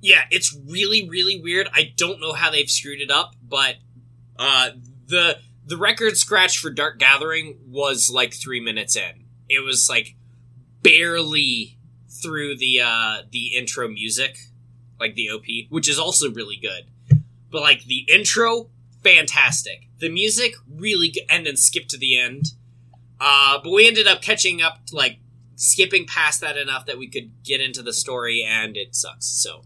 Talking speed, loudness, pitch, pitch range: 170 wpm, -18 LUFS, 130 Hz, 120-160 Hz